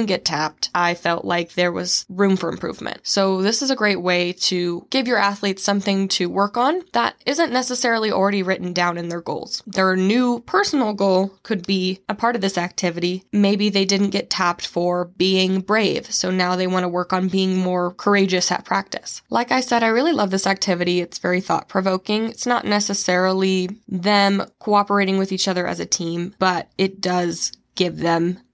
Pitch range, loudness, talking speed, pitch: 180-205 Hz, -20 LUFS, 195 wpm, 190 Hz